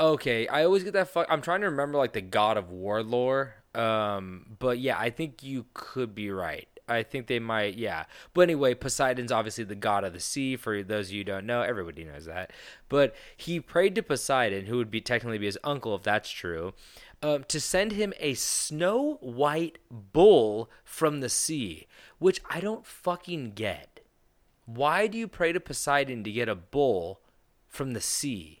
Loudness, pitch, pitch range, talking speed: -28 LUFS, 125 Hz, 110-155 Hz, 195 wpm